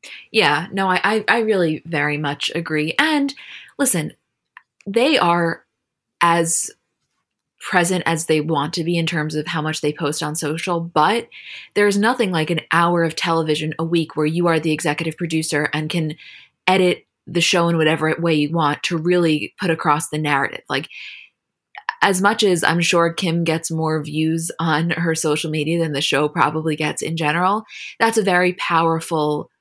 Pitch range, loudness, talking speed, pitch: 155-175 Hz, -19 LUFS, 170 wpm, 165 Hz